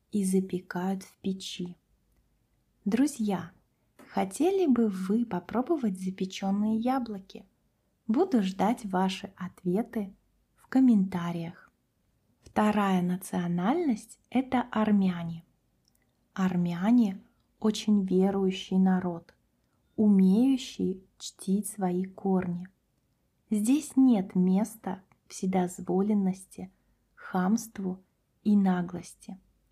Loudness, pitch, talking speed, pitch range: -28 LUFS, 195 Hz, 75 wpm, 185-215 Hz